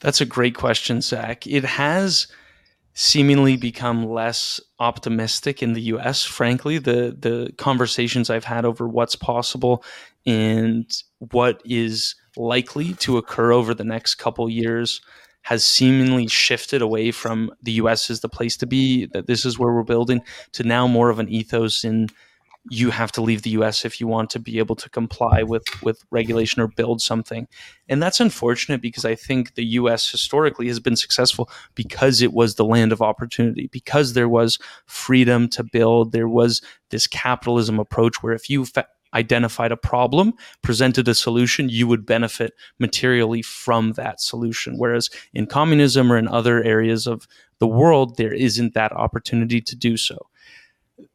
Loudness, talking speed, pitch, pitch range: -20 LUFS, 170 wpm, 120 Hz, 115-125 Hz